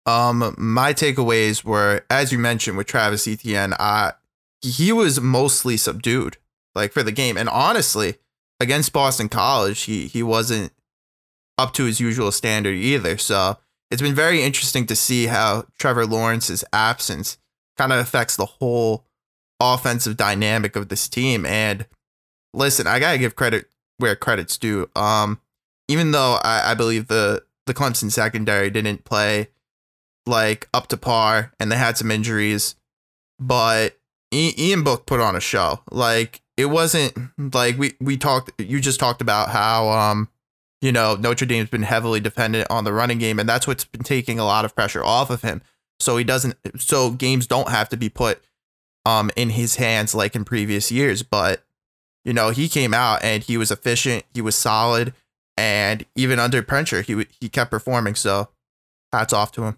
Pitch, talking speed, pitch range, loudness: 115 Hz, 175 wpm, 110-125 Hz, -20 LUFS